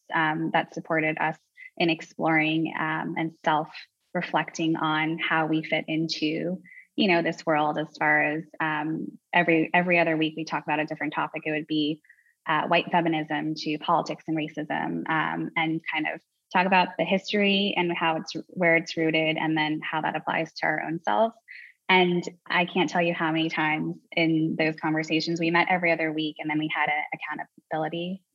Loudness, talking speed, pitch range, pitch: -26 LUFS, 185 wpm, 155-170 Hz, 160 Hz